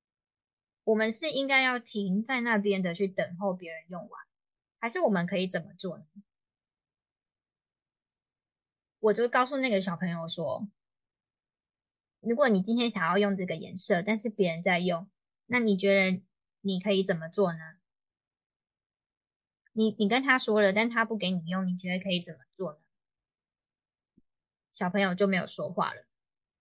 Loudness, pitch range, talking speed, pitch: -28 LUFS, 175-220 Hz, 220 characters per minute, 195 Hz